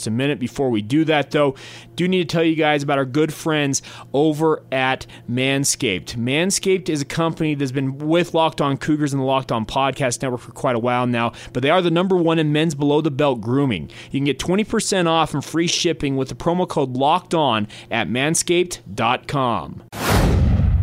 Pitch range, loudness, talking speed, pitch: 125-160 Hz, -20 LUFS, 200 wpm, 145 Hz